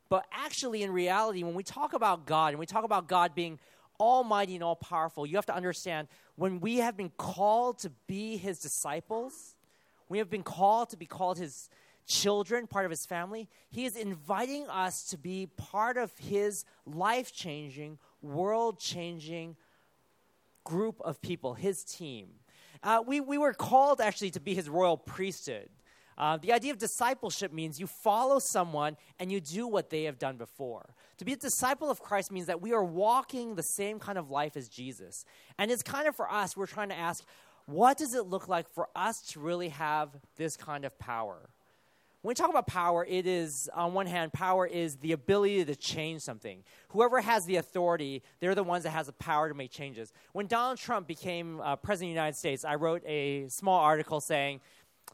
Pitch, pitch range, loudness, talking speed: 185 Hz, 155-215 Hz, -32 LUFS, 195 wpm